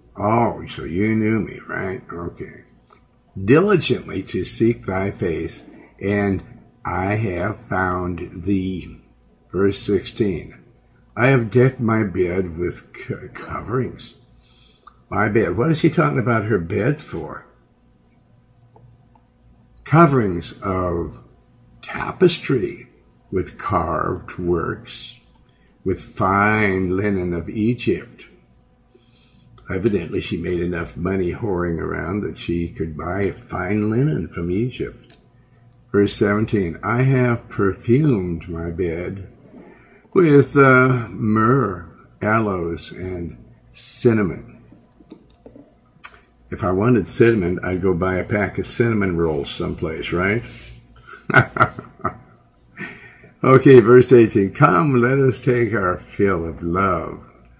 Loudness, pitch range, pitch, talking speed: -19 LUFS, 90-120 Hz, 100 Hz, 105 wpm